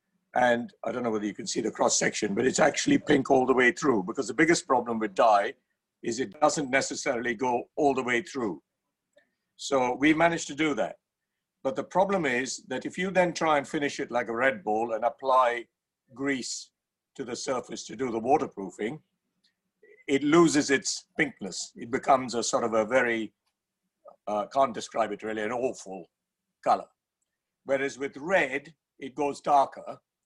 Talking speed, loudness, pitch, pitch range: 180 wpm, -27 LUFS, 135 Hz, 120-155 Hz